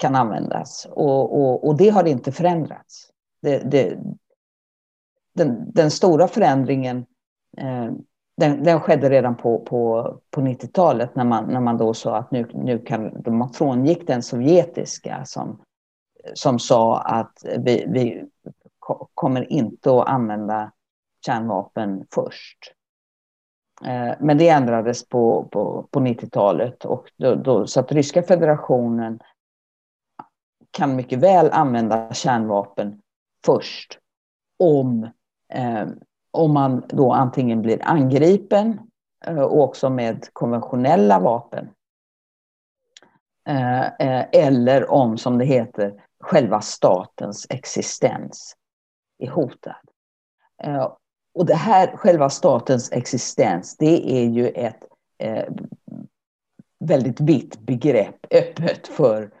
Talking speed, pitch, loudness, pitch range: 110 wpm, 130 Hz, -19 LUFS, 115-150 Hz